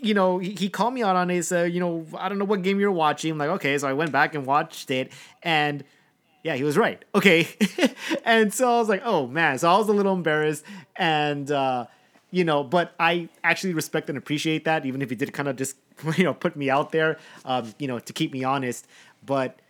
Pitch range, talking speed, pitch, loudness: 140-185 Hz, 240 wpm, 160 Hz, -24 LUFS